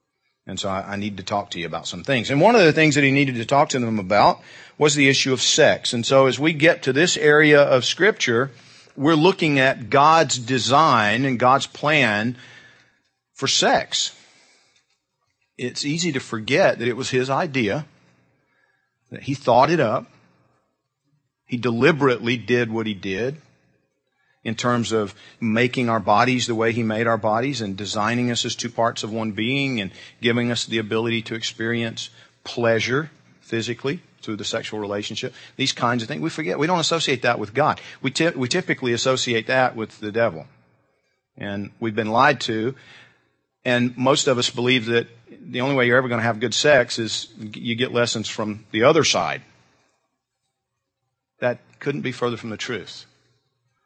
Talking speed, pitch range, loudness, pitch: 175 wpm, 110-135 Hz, -20 LUFS, 120 Hz